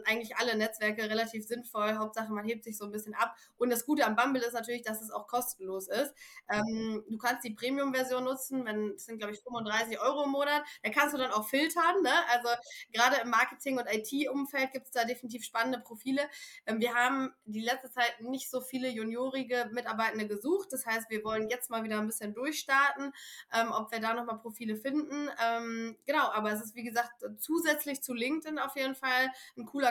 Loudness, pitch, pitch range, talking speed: -32 LUFS, 240 Hz, 225-270 Hz, 205 wpm